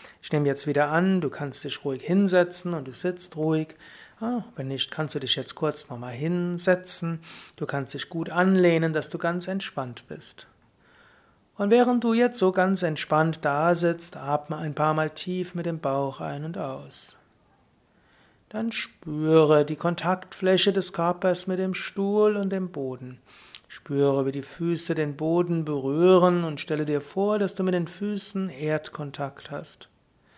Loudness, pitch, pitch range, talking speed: -26 LUFS, 165 Hz, 150-185 Hz, 165 wpm